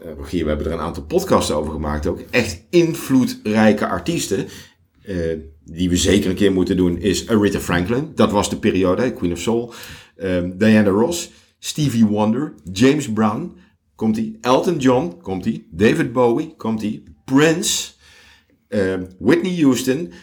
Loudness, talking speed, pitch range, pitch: -19 LUFS, 140 wpm, 90-125 Hz, 105 Hz